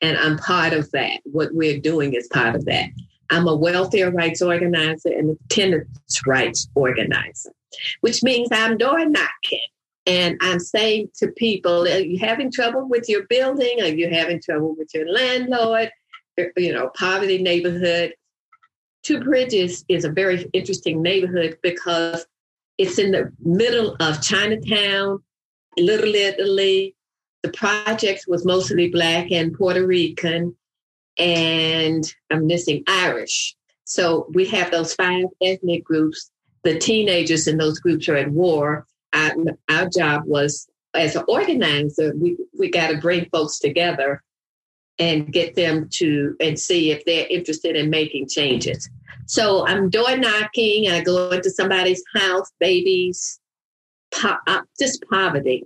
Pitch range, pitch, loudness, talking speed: 160-195 Hz, 175 Hz, -19 LUFS, 145 wpm